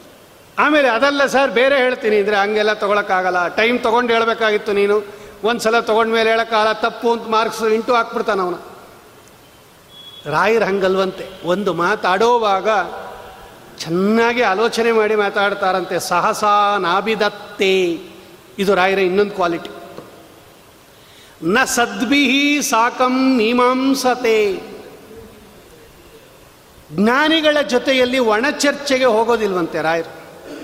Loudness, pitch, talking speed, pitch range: -16 LUFS, 220 Hz, 85 wpm, 195-245 Hz